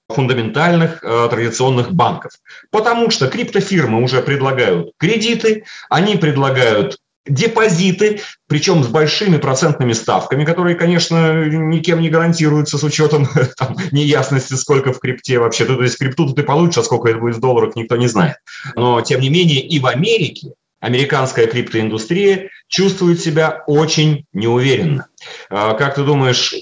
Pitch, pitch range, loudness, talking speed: 150 Hz, 130-170 Hz, -14 LUFS, 135 wpm